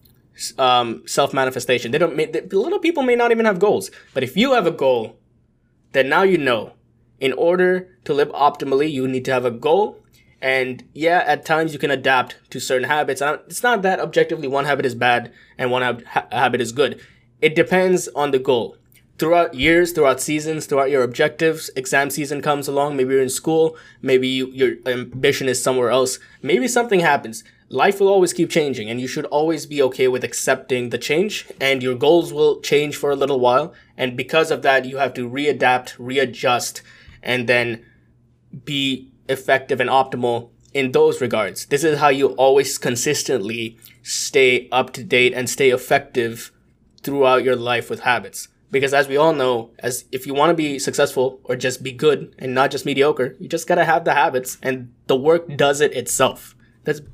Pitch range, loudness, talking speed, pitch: 125-160 Hz, -19 LUFS, 195 wpm, 140 Hz